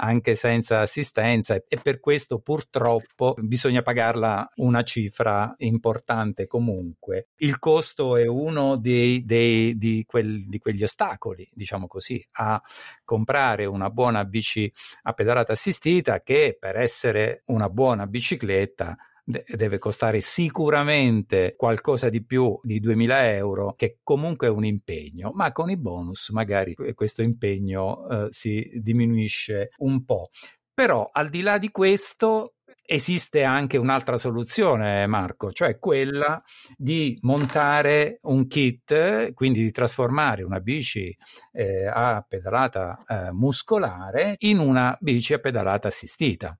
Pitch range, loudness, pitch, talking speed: 110-140 Hz, -23 LUFS, 120 Hz, 125 wpm